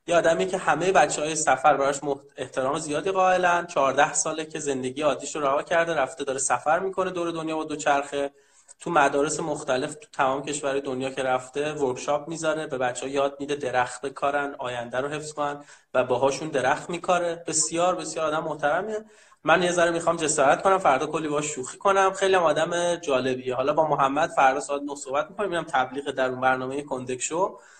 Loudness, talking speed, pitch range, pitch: -25 LUFS, 175 wpm, 135-165 Hz, 150 Hz